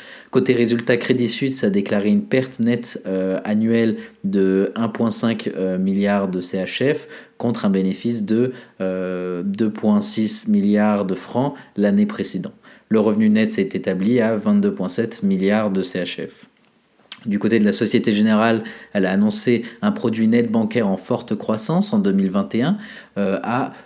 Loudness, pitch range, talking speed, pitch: -20 LUFS, 100-120 Hz, 145 wpm, 110 Hz